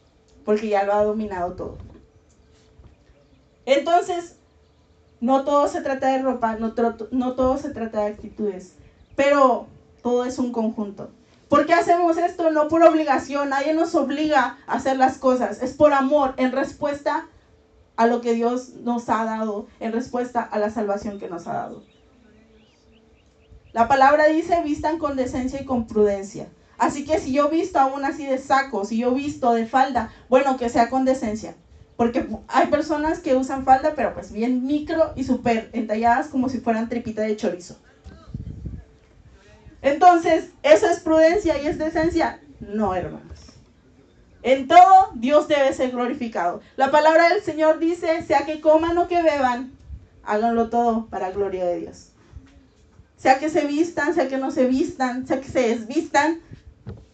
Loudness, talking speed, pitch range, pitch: -21 LUFS, 160 wpm, 235-305 Hz, 265 Hz